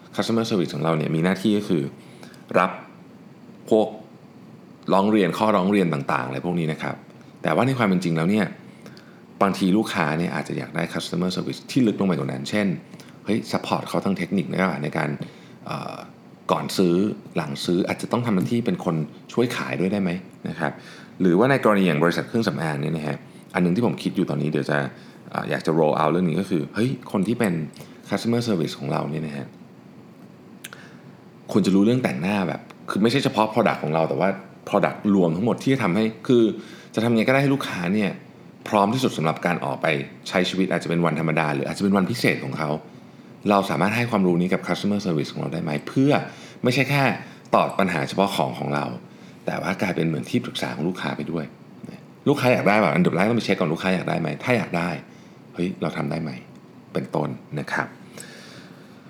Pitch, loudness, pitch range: 90 Hz, -23 LUFS, 80-110 Hz